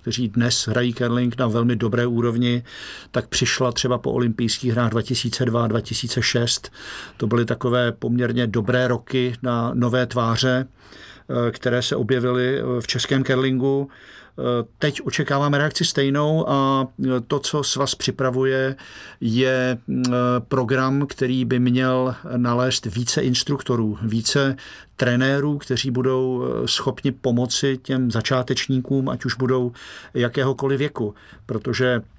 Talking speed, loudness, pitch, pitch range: 115 wpm, -21 LUFS, 125 Hz, 120-130 Hz